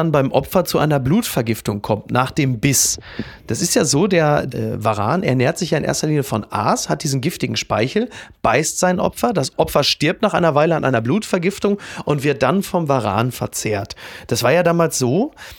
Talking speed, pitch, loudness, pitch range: 200 wpm, 145 Hz, -18 LUFS, 125-170 Hz